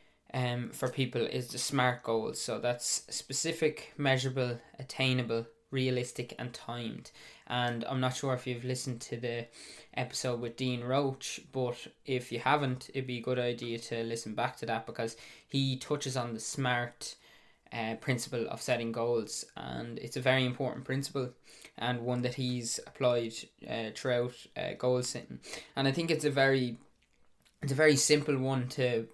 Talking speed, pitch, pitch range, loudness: 165 wpm, 125 Hz, 120-135 Hz, -33 LUFS